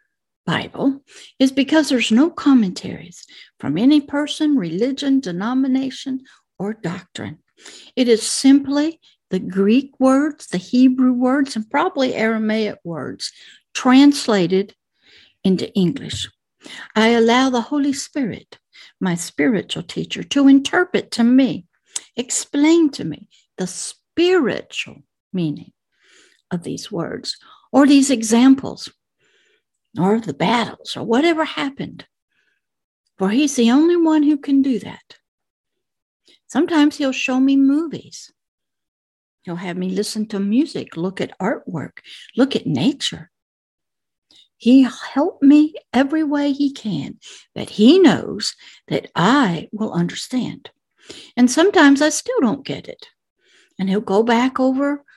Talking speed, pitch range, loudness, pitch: 120 wpm, 215-290 Hz, -18 LUFS, 260 Hz